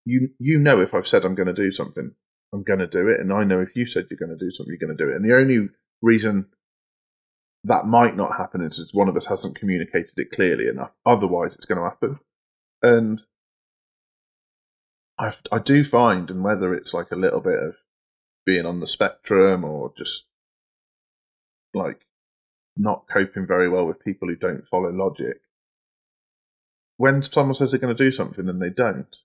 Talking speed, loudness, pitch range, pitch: 195 wpm, -21 LUFS, 90-125 Hz, 105 Hz